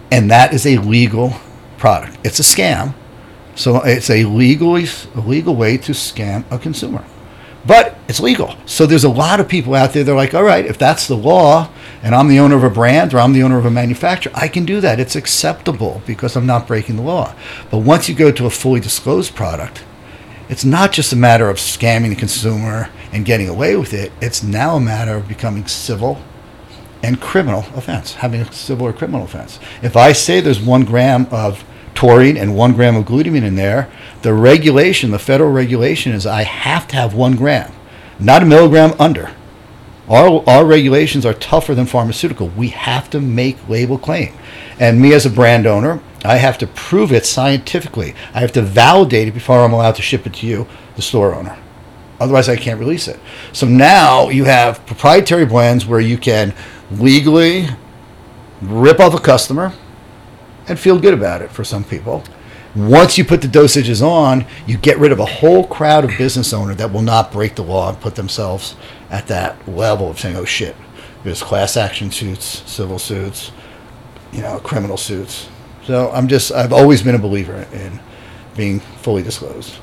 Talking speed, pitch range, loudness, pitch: 195 wpm, 110-135 Hz, -12 LUFS, 120 Hz